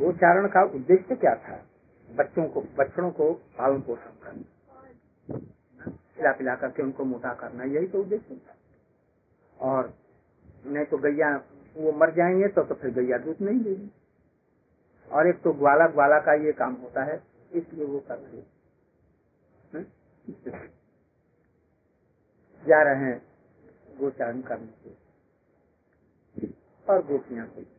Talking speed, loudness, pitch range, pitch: 120 wpm, -25 LUFS, 125-175 Hz, 145 Hz